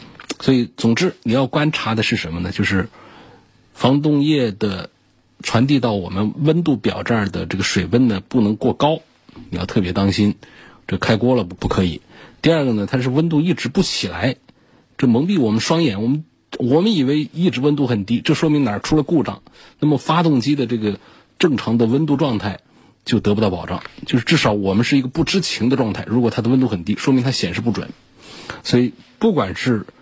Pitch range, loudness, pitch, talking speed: 105-150 Hz, -18 LUFS, 125 Hz, 295 characters per minute